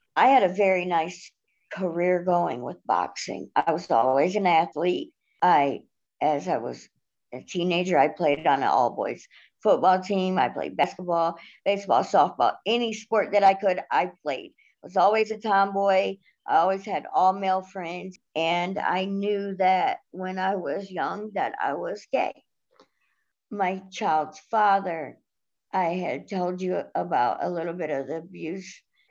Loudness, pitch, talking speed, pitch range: -25 LUFS, 190 Hz, 155 wpm, 175-200 Hz